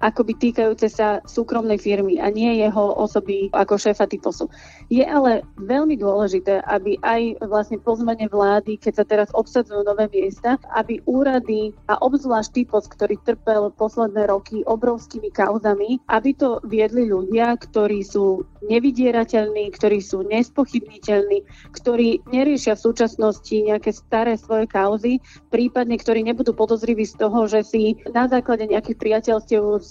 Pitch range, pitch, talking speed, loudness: 210-235 Hz, 220 Hz, 135 wpm, -20 LUFS